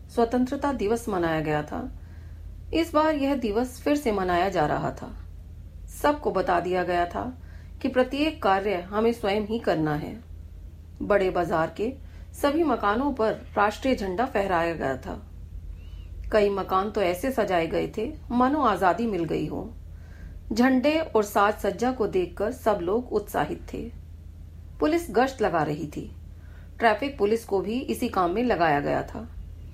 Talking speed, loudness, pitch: 155 wpm, -25 LUFS, 190 Hz